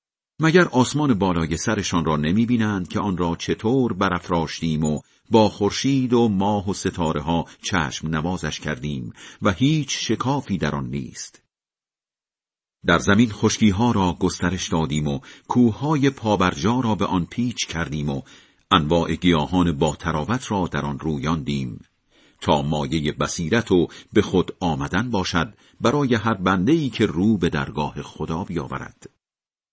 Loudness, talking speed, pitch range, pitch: -22 LUFS, 140 wpm, 80-115 Hz, 95 Hz